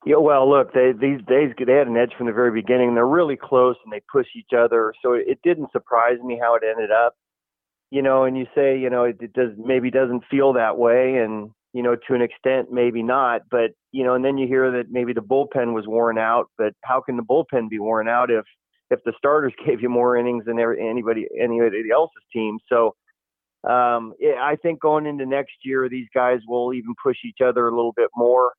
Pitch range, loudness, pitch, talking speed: 120-130 Hz, -20 LUFS, 125 Hz, 230 wpm